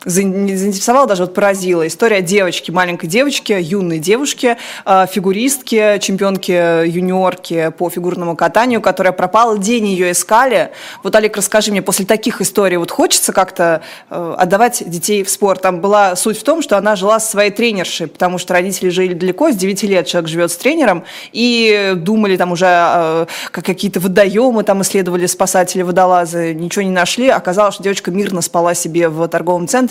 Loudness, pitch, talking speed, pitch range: -13 LUFS, 195 Hz, 165 wpm, 180-210 Hz